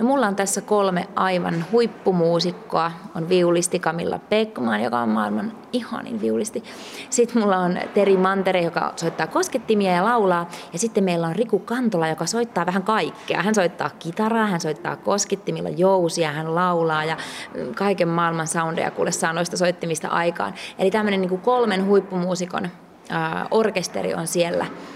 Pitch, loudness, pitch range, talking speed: 185 Hz, -22 LUFS, 170-220 Hz, 145 wpm